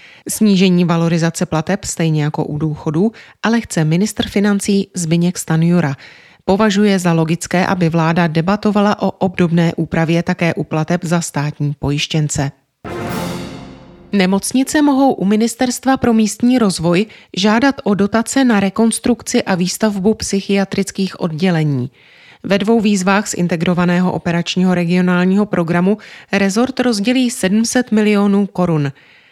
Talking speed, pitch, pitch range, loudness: 115 wpm, 185 Hz, 165-210 Hz, -15 LUFS